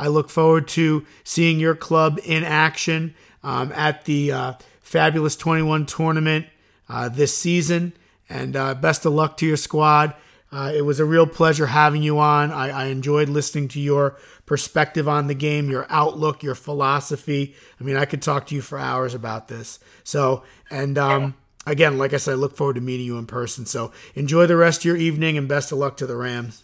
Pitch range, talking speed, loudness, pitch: 135-155 Hz, 205 wpm, -20 LUFS, 145 Hz